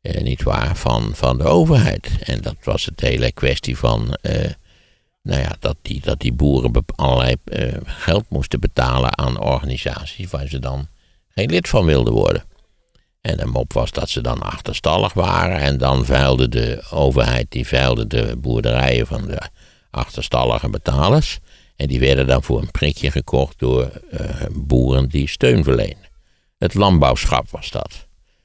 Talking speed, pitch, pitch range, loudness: 160 wpm, 65 Hz, 60-70 Hz, -18 LUFS